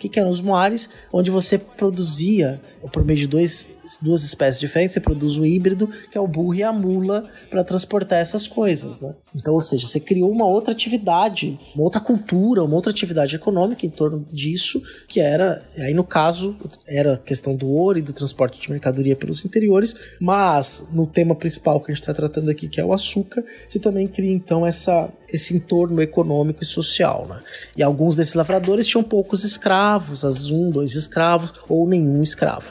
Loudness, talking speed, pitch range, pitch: -20 LUFS, 190 wpm, 150-195 Hz, 170 Hz